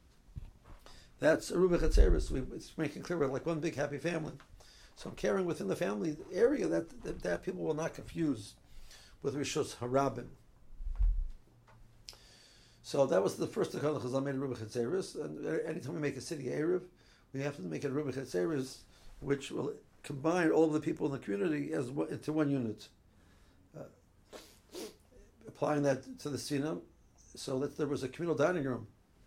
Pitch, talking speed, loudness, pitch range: 135 Hz, 160 wpm, -35 LUFS, 115-150 Hz